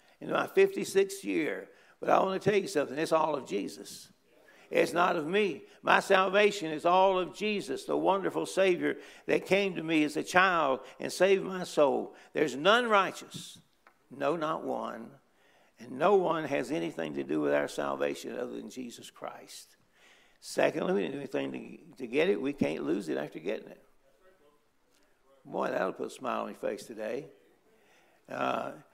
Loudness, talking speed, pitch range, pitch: -30 LUFS, 175 wpm, 150-195 Hz, 180 Hz